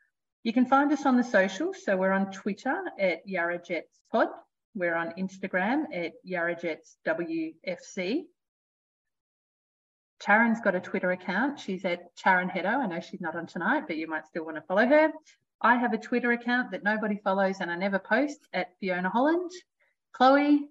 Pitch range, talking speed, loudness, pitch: 180-270 Hz, 175 wpm, -28 LUFS, 200 Hz